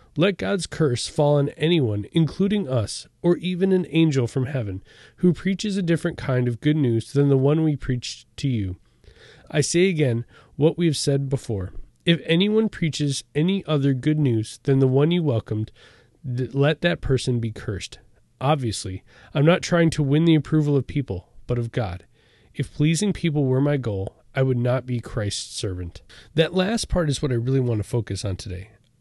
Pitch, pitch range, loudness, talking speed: 140 Hz, 120-160 Hz, -23 LUFS, 190 wpm